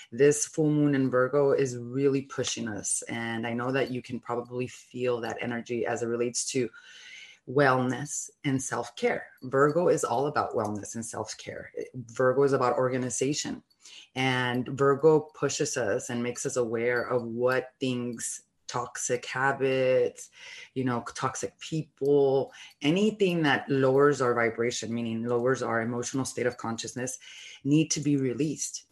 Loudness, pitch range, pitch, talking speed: -28 LUFS, 120-140 Hz, 130 Hz, 145 wpm